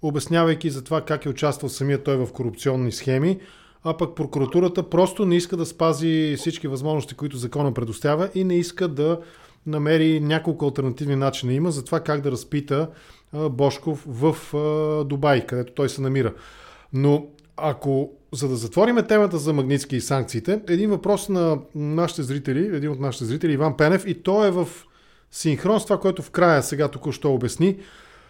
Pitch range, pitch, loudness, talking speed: 140-170 Hz, 150 Hz, -23 LUFS, 170 wpm